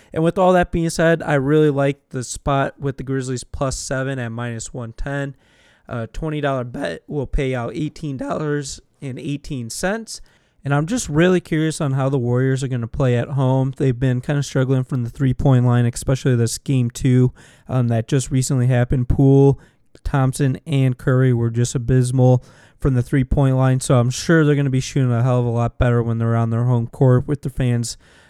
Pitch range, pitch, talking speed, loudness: 125-145 Hz, 135 Hz, 200 wpm, -19 LUFS